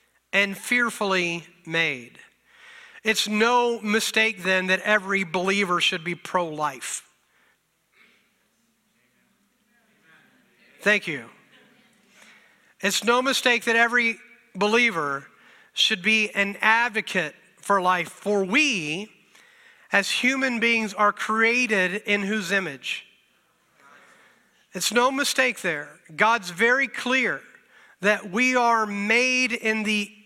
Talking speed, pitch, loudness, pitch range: 100 wpm, 210 Hz, -22 LUFS, 185-235 Hz